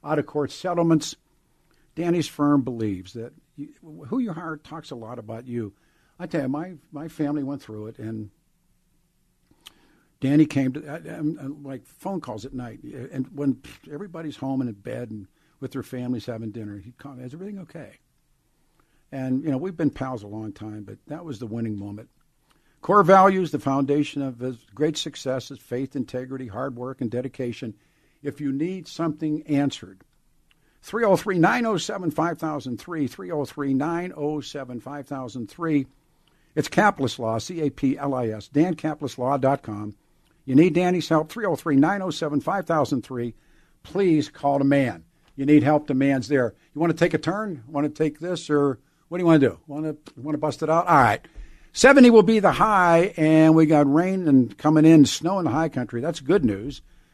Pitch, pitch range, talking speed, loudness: 145 Hz, 130-160 Hz, 165 wpm, -22 LUFS